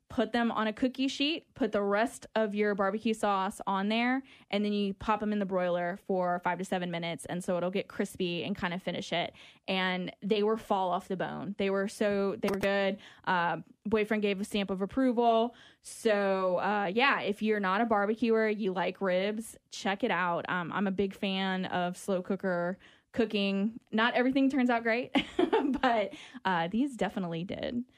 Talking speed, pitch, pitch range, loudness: 195 wpm, 205 Hz, 190-225 Hz, -31 LUFS